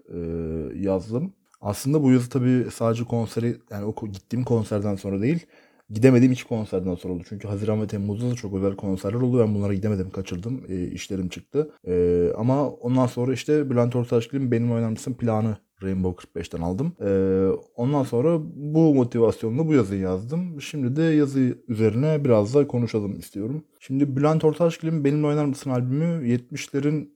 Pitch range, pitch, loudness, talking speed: 100-140 Hz, 120 Hz, -24 LUFS, 160 wpm